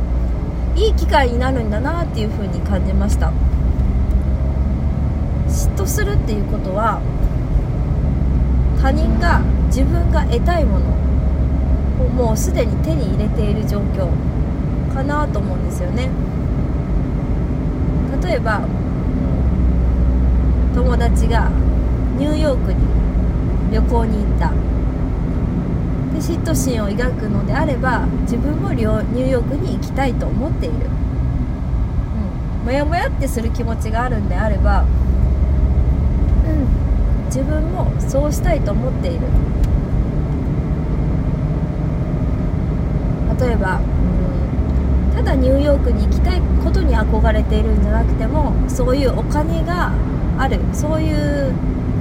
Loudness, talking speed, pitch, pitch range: -18 LUFS, 225 characters per minute, 65 Hz, 65-70 Hz